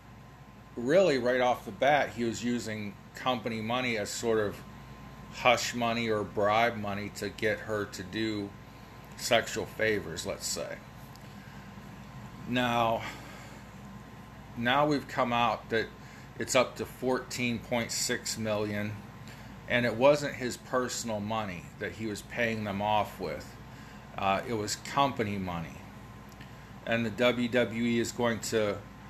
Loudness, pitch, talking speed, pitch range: -30 LUFS, 115 Hz, 130 wpm, 105-120 Hz